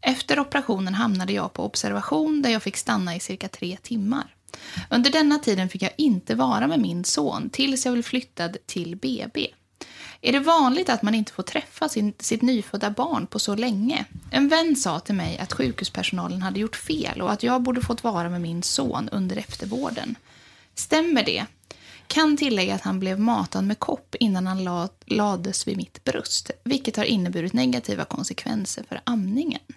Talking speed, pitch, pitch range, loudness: 180 wpm, 230 Hz, 190-265 Hz, -24 LUFS